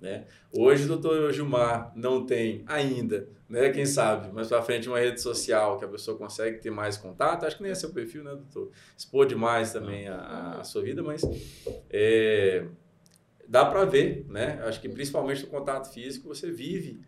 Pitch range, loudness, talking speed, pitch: 115-195 Hz, -27 LUFS, 185 wpm, 140 Hz